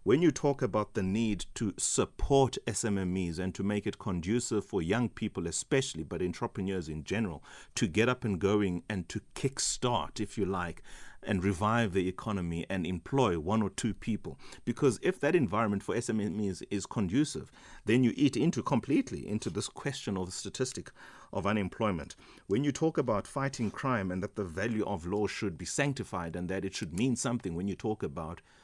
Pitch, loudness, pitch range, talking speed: 105 Hz, -32 LUFS, 95-120 Hz, 190 wpm